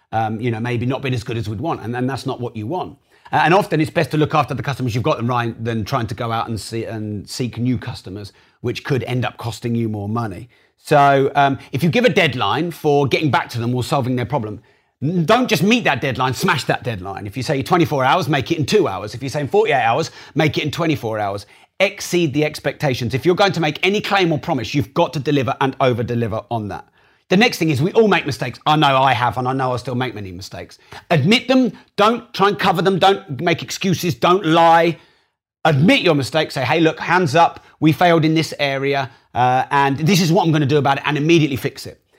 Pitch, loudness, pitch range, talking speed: 140 Hz, -18 LUFS, 120-165 Hz, 250 wpm